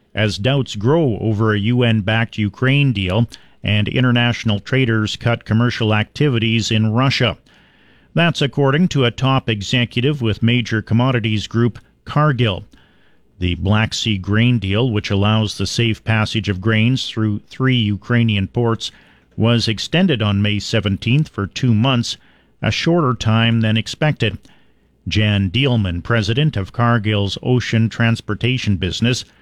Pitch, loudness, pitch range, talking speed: 115 Hz, -17 LUFS, 105-125 Hz, 135 wpm